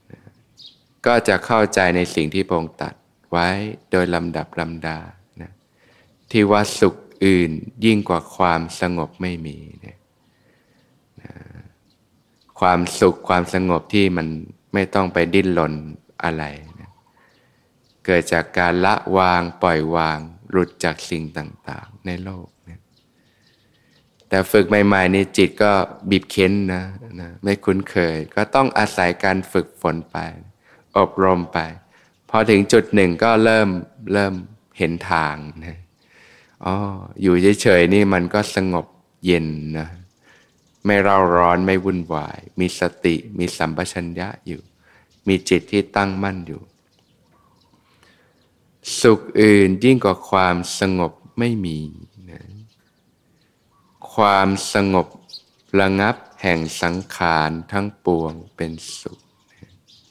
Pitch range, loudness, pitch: 85-100 Hz, -19 LUFS, 90 Hz